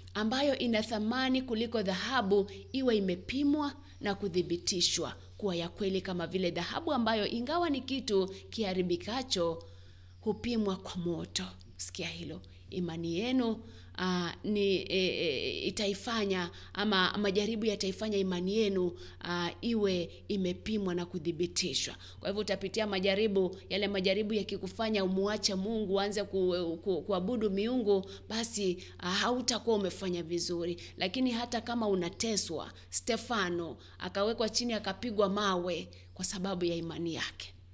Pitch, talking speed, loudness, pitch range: 195 Hz, 120 wpm, -33 LUFS, 175-220 Hz